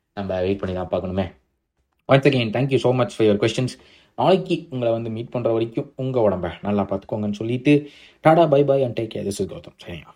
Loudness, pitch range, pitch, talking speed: -21 LUFS, 100-135 Hz, 115 Hz, 190 wpm